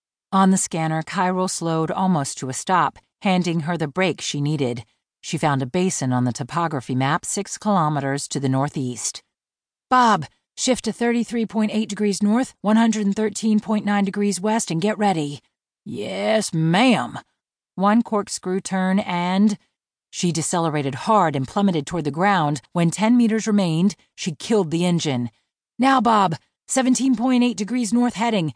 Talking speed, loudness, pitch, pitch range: 145 wpm, -21 LUFS, 190 Hz, 155-215 Hz